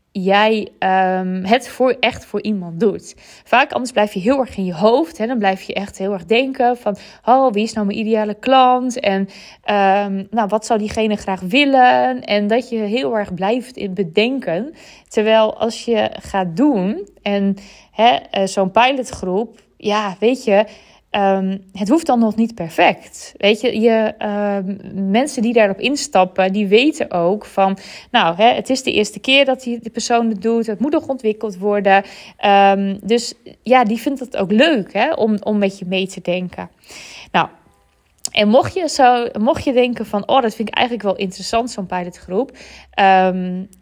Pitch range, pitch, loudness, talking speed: 195-235 Hz, 215 Hz, -17 LUFS, 180 wpm